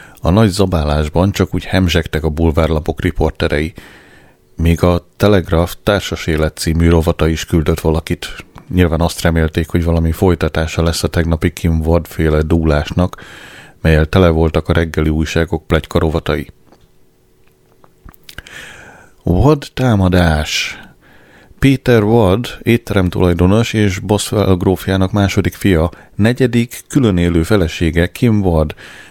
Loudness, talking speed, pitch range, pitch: -14 LUFS, 115 wpm, 80-95 Hz, 85 Hz